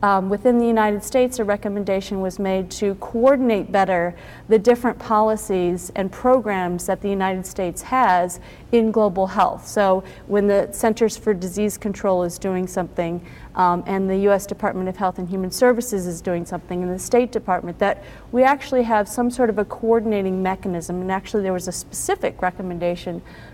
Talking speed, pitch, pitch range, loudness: 175 wpm, 200 Hz, 185-225 Hz, -21 LUFS